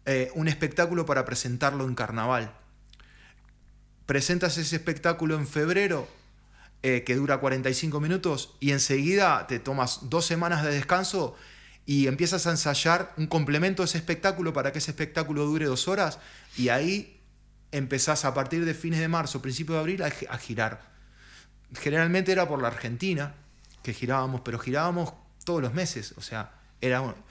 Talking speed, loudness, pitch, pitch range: 160 wpm, -27 LUFS, 145 Hz, 130-170 Hz